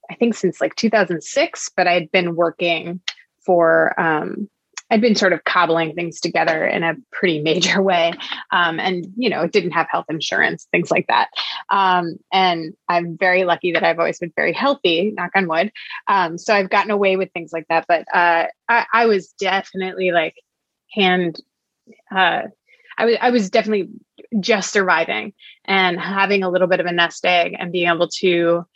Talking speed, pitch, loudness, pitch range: 180 wpm, 180 Hz, -18 LUFS, 170-200 Hz